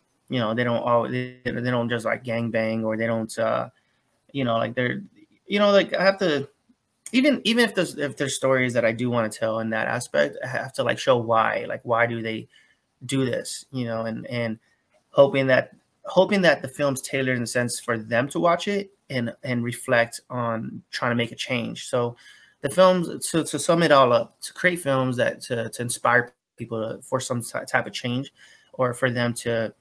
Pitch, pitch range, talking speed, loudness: 125 Hz, 115-145 Hz, 220 wpm, -24 LUFS